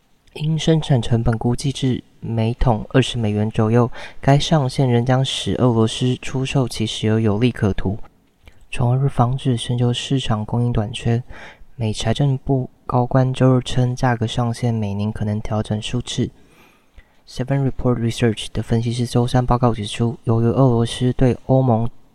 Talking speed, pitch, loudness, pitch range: 280 characters per minute, 120 Hz, -19 LUFS, 110-130 Hz